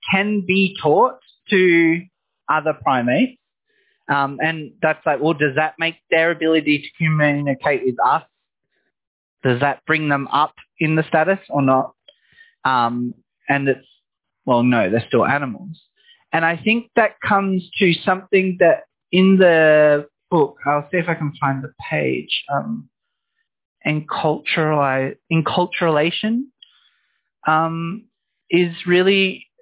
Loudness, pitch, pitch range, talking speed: -18 LUFS, 165 Hz, 150-195 Hz, 130 wpm